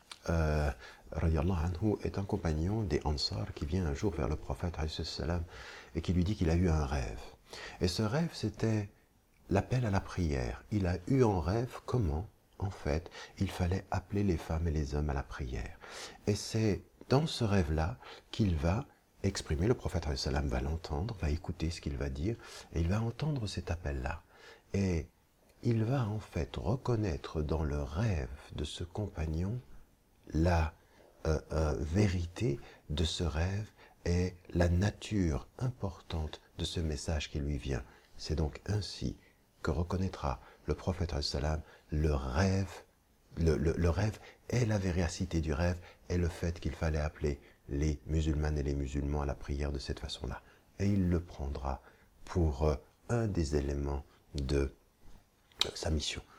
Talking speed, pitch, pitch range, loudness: 165 wpm, 85 Hz, 75-100 Hz, -35 LUFS